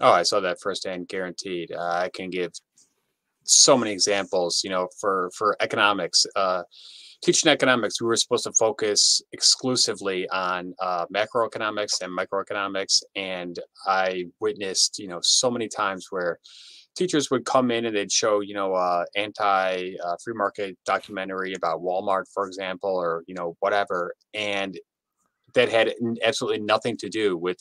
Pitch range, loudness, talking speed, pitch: 90-115 Hz, -23 LUFS, 160 wpm, 95 Hz